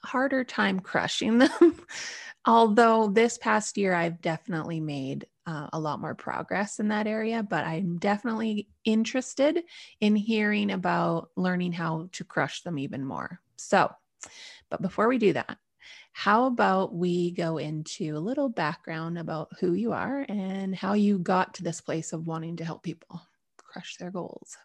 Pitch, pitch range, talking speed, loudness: 190 Hz, 165-225 Hz, 160 wpm, -27 LUFS